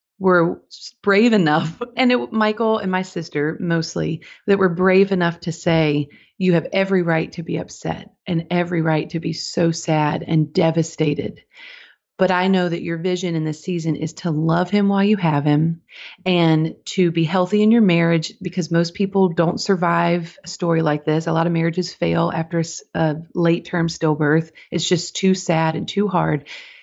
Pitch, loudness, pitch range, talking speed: 170 Hz, -19 LUFS, 160-190 Hz, 185 wpm